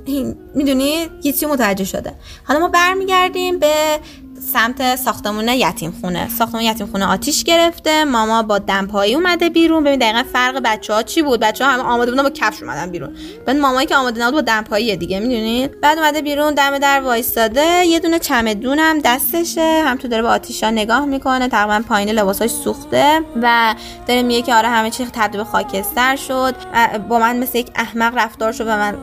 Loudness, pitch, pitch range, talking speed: -15 LUFS, 250 Hz, 220-295 Hz, 185 wpm